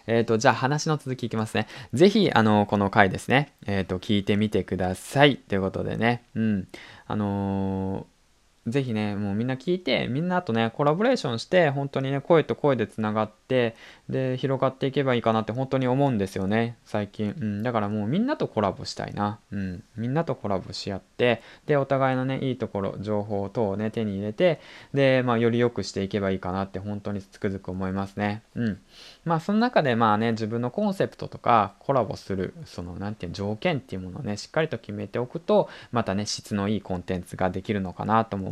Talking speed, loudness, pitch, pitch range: 420 characters per minute, -26 LUFS, 110 Hz, 100-130 Hz